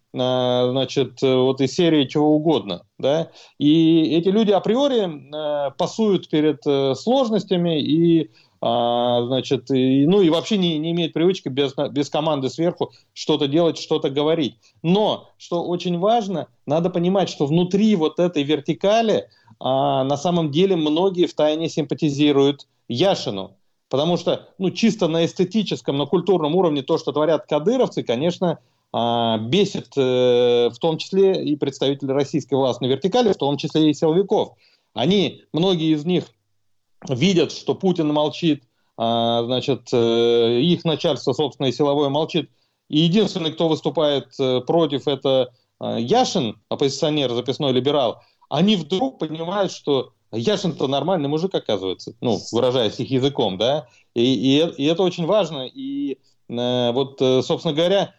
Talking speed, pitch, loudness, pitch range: 130 wpm, 150 Hz, -20 LUFS, 130-175 Hz